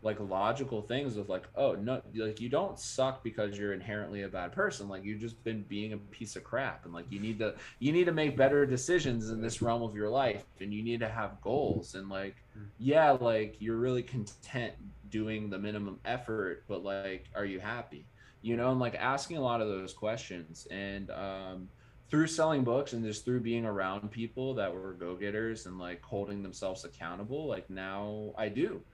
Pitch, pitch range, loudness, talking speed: 110 Hz, 100-120 Hz, -34 LUFS, 205 wpm